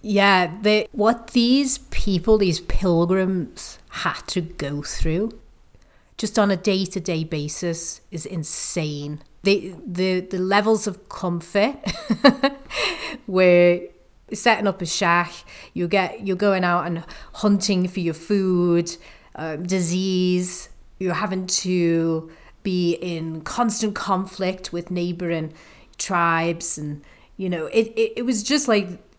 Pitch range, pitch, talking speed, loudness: 170-205 Hz, 185 Hz, 125 wpm, -22 LUFS